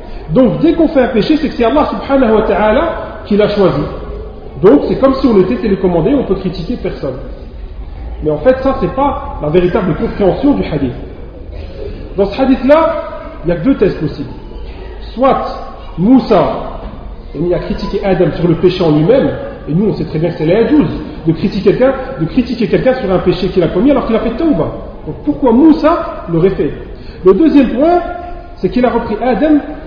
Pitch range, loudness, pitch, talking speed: 180-275 Hz, -12 LUFS, 220 Hz, 195 wpm